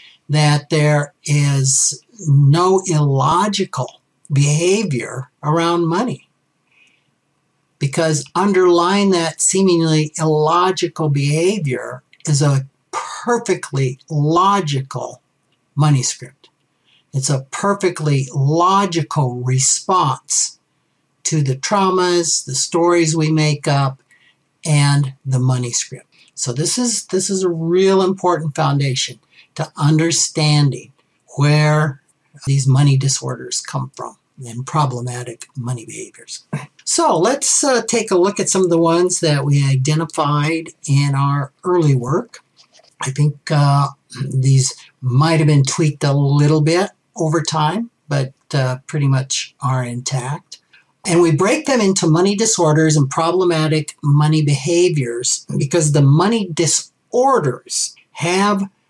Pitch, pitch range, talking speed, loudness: 155 Hz, 140-175 Hz, 115 wpm, -16 LUFS